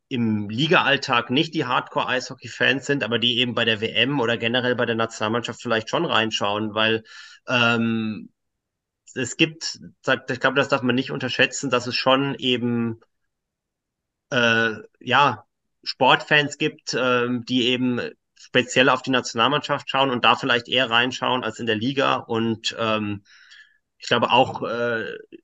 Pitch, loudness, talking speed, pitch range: 125 Hz, -21 LUFS, 150 wpm, 115-135 Hz